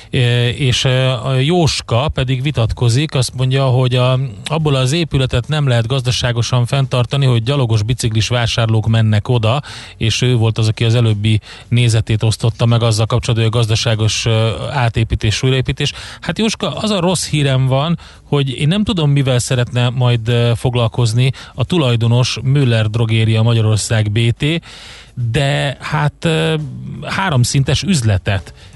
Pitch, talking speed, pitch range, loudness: 125 Hz, 135 wpm, 115-140 Hz, -15 LUFS